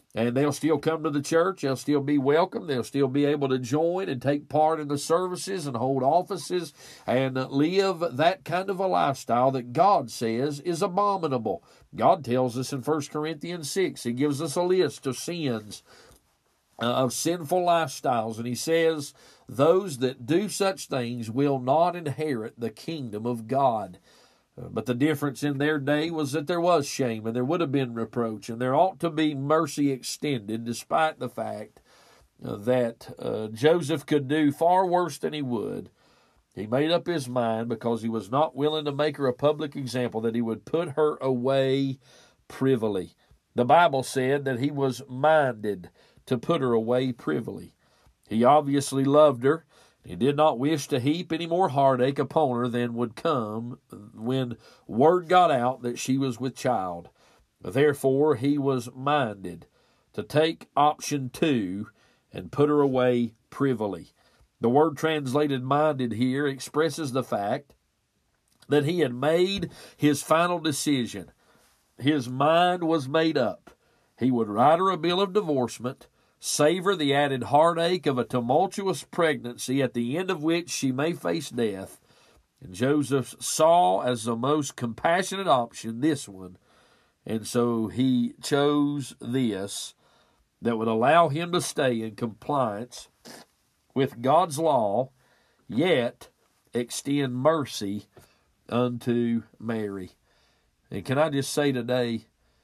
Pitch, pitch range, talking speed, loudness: 140 Hz, 120-155 Hz, 155 wpm, -26 LUFS